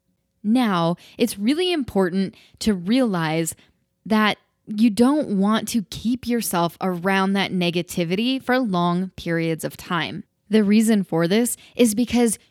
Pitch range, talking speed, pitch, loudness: 180-235 Hz, 130 wpm, 210 Hz, -21 LUFS